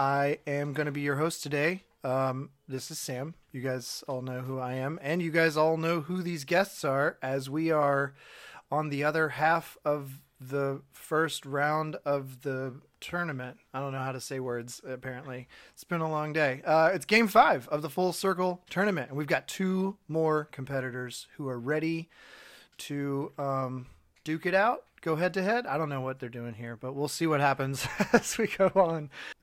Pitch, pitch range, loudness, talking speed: 145 Hz, 130-165 Hz, -30 LUFS, 200 wpm